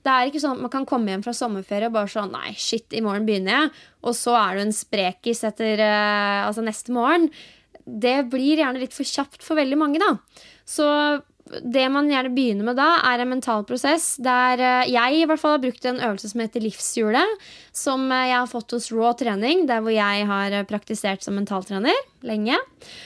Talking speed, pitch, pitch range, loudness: 200 wpm, 245 Hz, 215-275 Hz, -22 LUFS